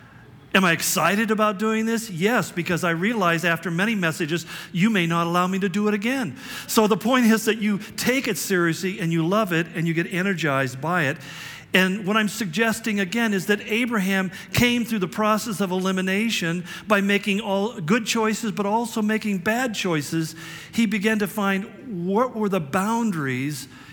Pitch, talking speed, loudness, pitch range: 200 Hz, 185 wpm, -22 LUFS, 170-220 Hz